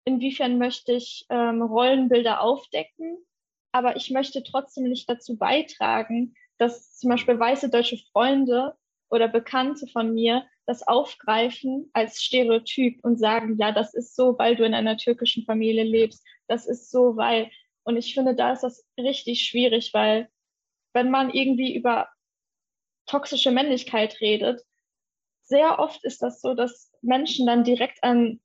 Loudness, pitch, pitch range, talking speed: -23 LUFS, 245 Hz, 230-260 Hz, 150 wpm